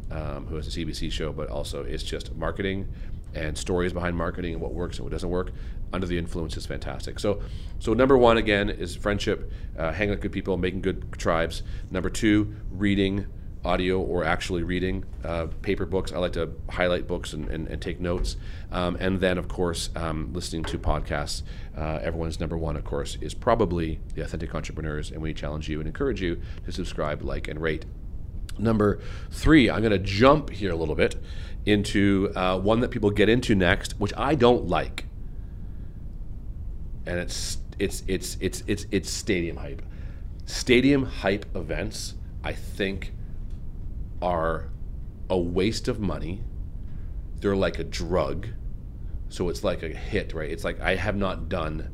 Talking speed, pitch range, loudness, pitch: 175 wpm, 80-100 Hz, -27 LUFS, 90 Hz